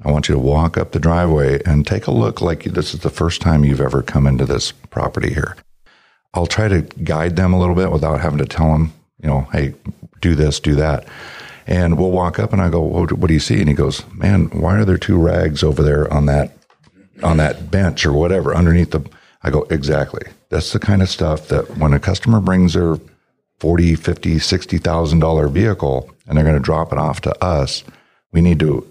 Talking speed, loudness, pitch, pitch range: 225 wpm, -16 LUFS, 80 Hz, 75-90 Hz